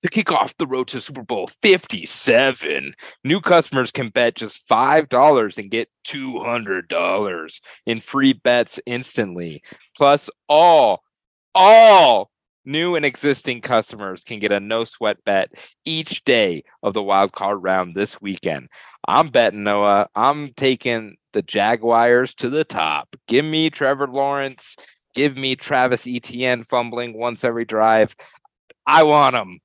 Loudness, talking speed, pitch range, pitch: -18 LUFS, 145 wpm, 115-140 Hz, 125 Hz